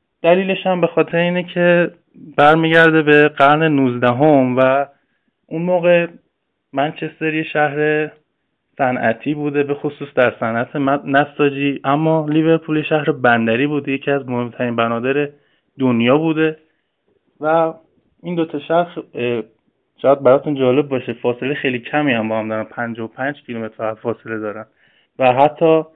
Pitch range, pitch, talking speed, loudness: 125-155 Hz, 145 Hz, 130 wpm, -17 LUFS